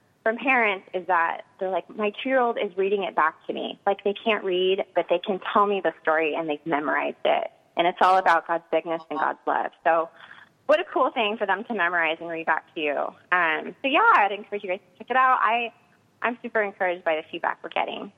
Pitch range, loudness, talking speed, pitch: 170-230 Hz, -24 LUFS, 245 wpm, 195 Hz